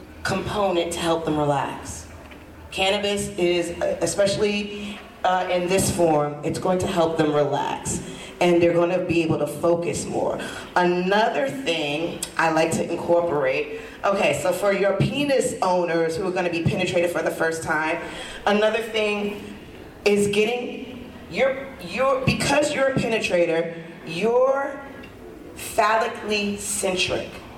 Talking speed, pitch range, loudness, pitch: 135 wpm, 170-215 Hz, -22 LUFS, 185 Hz